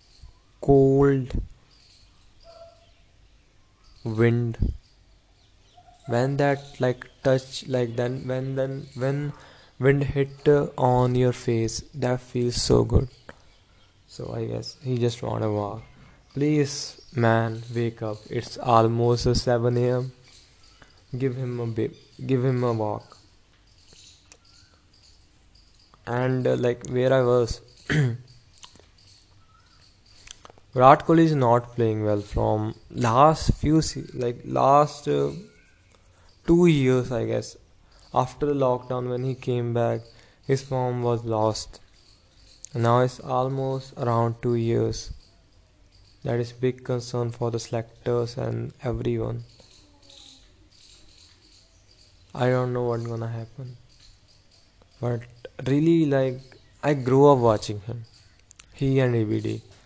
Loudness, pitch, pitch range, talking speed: -24 LUFS, 115 Hz, 100-130 Hz, 110 wpm